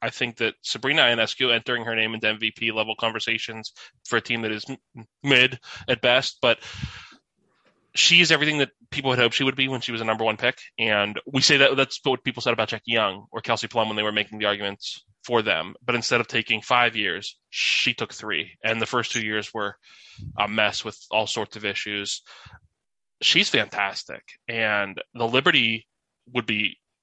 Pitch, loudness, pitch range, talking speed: 115 Hz, -22 LUFS, 110-125 Hz, 200 wpm